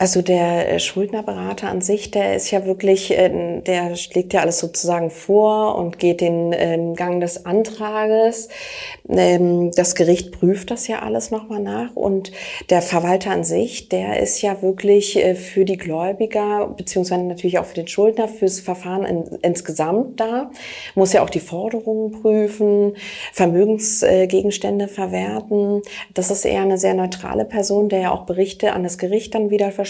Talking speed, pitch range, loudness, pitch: 155 wpm, 175-210 Hz, -19 LUFS, 190 Hz